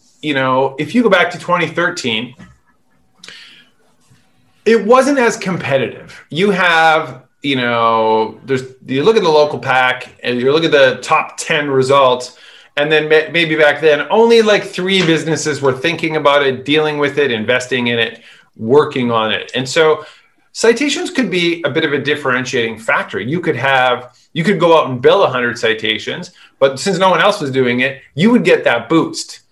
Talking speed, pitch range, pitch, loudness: 180 wpm, 130-175 Hz, 150 Hz, -14 LUFS